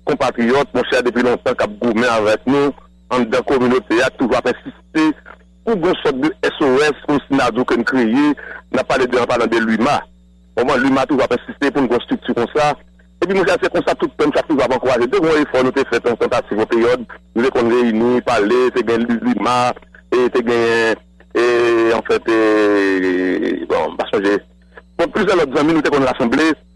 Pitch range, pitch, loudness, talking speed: 105-130 Hz, 120 Hz, -16 LUFS, 225 wpm